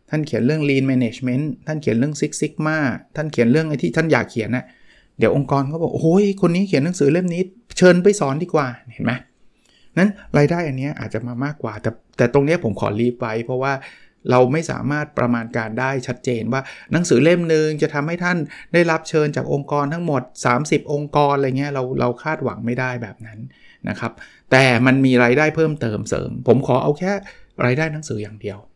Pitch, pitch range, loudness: 140 Hz, 125-155 Hz, -19 LUFS